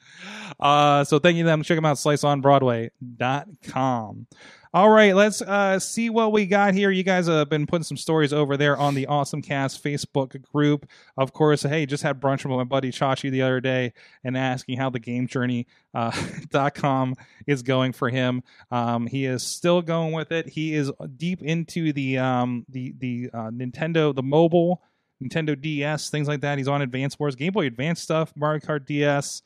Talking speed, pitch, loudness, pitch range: 190 wpm, 145 Hz, -23 LUFS, 130-160 Hz